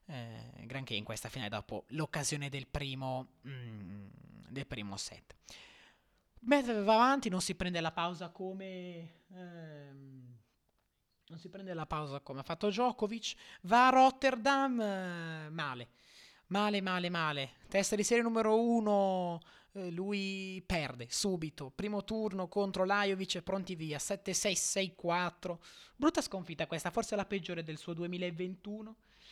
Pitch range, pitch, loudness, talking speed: 145-200 Hz, 180 Hz, -34 LUFS, 135 wpm